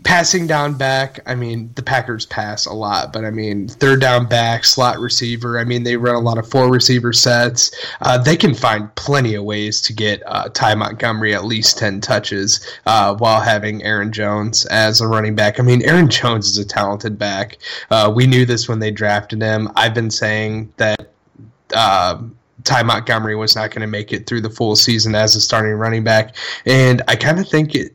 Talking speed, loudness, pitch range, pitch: 210 wpm, -15 LUFS, 110-125 Hz, 115 Hz